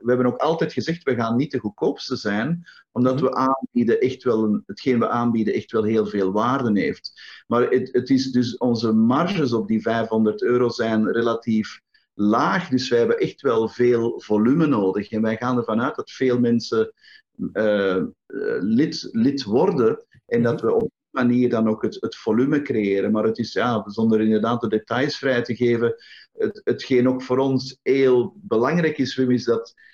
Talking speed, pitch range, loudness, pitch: 185 wpm, 110-135 Hz, -21 LUFS, 120 Hz